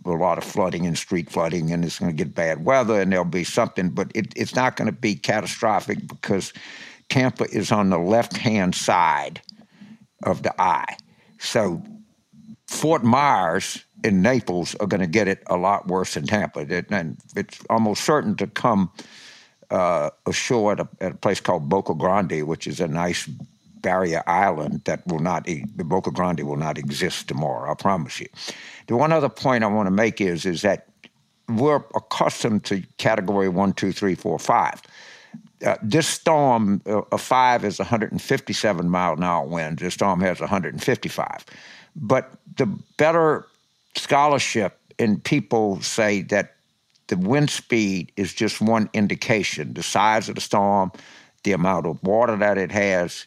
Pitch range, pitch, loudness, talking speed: 95-145 Hz, 105 Hz, -22 LUFS, 165 wpm